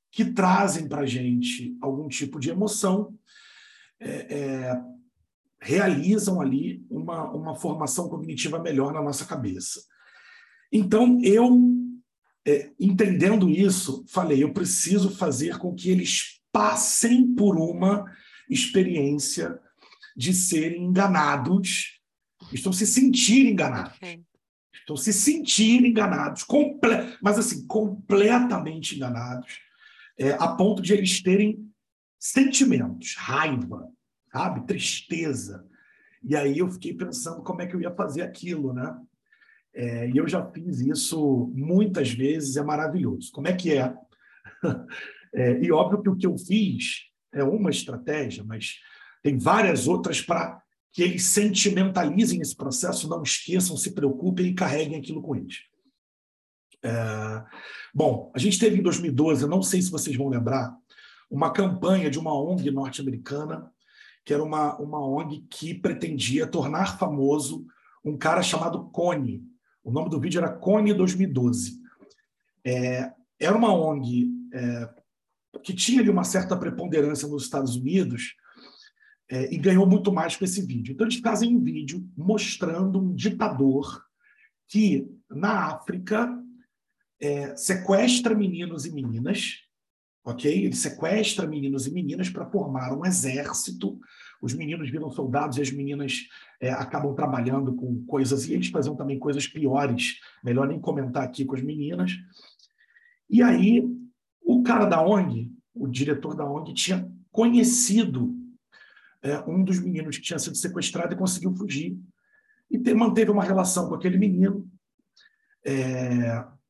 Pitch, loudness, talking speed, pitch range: 175 Hz, -24 LUFS, 135 wpm, 140-210 Hz